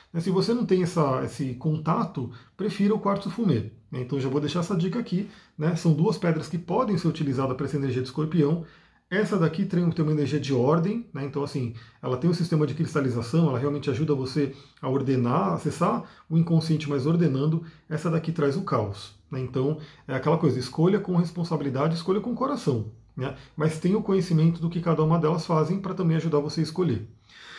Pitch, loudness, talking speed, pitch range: 155 Hz, -26 LUFS, 200 wpm, 140-175 Hz